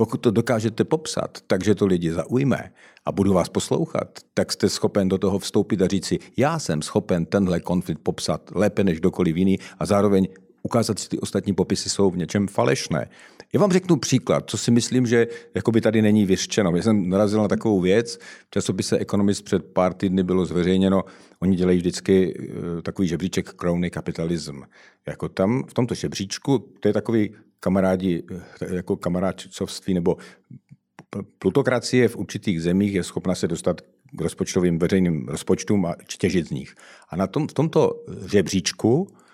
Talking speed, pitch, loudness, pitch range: 165 wpm, 95 Hz, -22 LUFS, 90-110 Hz